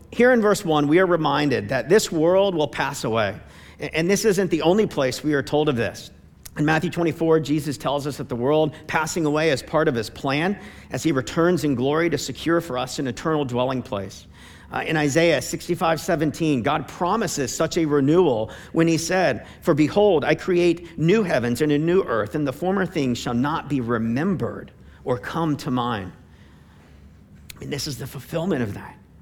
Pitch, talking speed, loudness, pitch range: 150 Hz, 195 wpm, -22 LUFS, 130-170 Hz